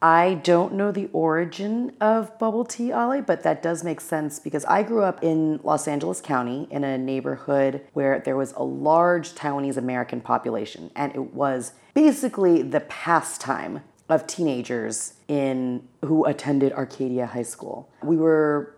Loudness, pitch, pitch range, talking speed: -24 LUFS, 150 Hz, 135-175 Hz, 155 wpm